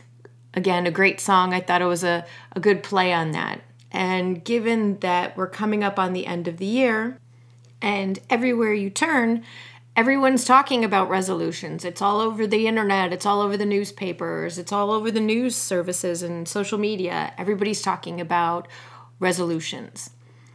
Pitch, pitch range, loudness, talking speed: 190 Hz, 175-210 Hz, -22 LUFS, 165 wpm